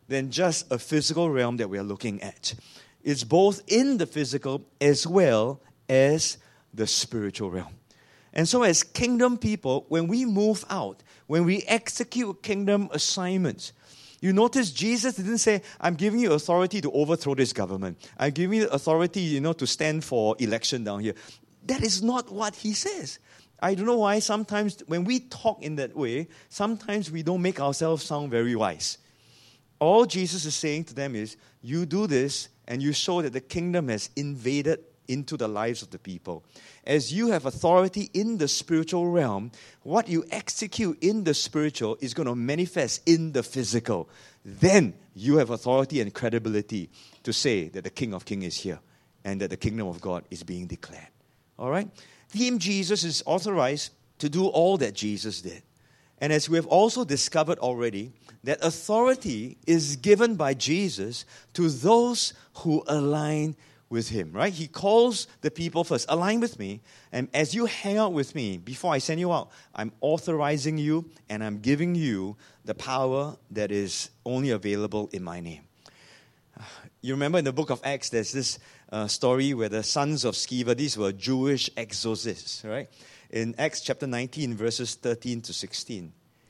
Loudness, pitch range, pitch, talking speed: -26 LUFS, 115-175 Hz, 145 Hz, 175 wpm